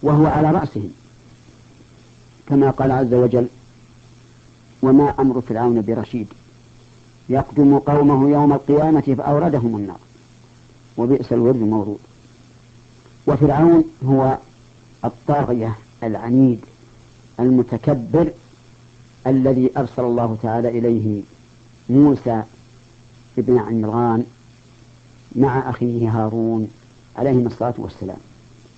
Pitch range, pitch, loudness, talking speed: 120-135 Hz, 120 Hz, -17 LUFS, 80 wpm